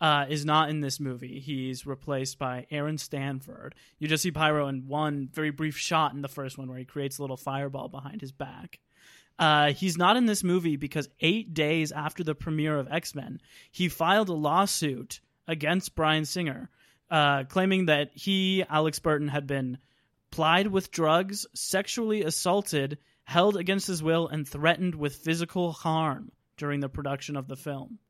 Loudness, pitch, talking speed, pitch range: -28 LUFS, 150 Hz, 175 wpm, 140-165 Hz